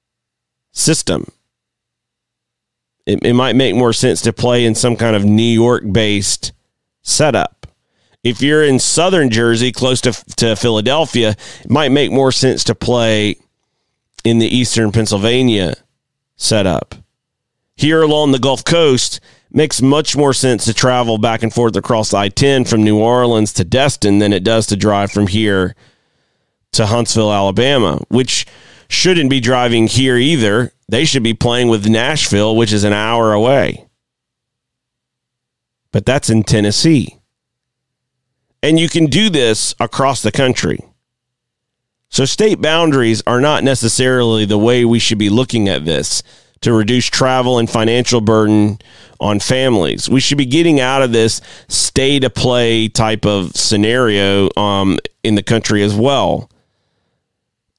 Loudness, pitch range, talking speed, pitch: -13 LUFS, 110-130 Hz, 145 wpm, 115 Hz